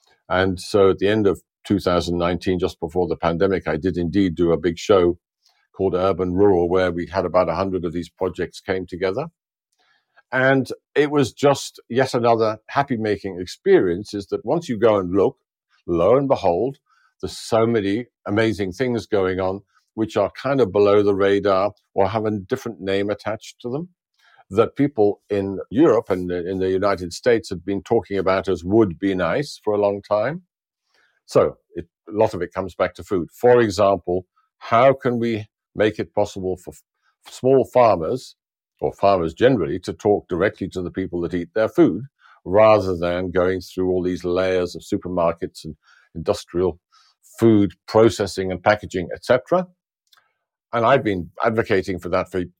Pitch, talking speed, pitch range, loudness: 95 Hz, 170 wpm, 90-110 Hz, -20 LUFS